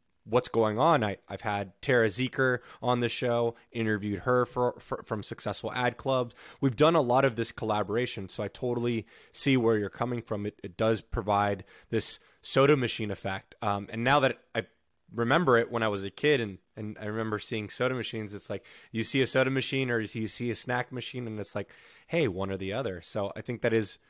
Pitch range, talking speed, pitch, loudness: 105-125 Hz, 215 wpm, 115 Hz, -29 LUFS